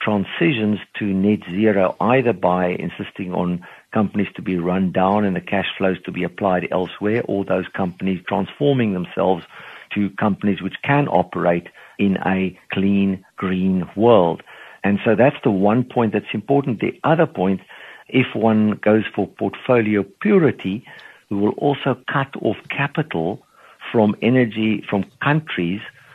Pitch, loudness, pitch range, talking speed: 100 Hz, -20 LUFS, 95-115 Hz, 145 wpm